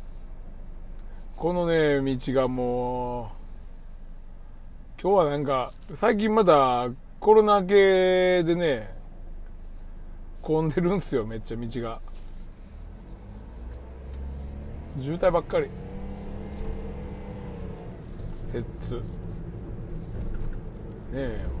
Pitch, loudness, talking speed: 110 Hz, -25 LUFS, 130 characters per minute